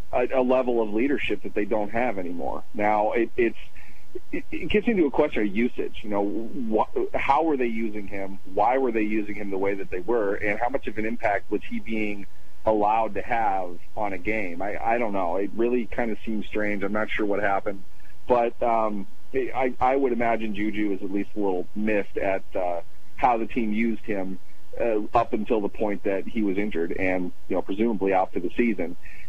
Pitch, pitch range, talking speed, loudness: 105 Hz, 100-115 Hz, 215 wpm, -26 LUFS